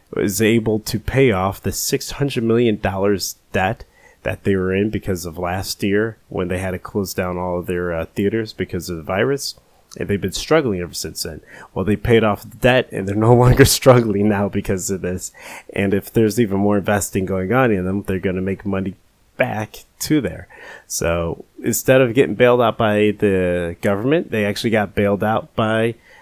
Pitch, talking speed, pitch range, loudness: 100 Hz, 200 wpm, 95-115 Hz, -19 LUFS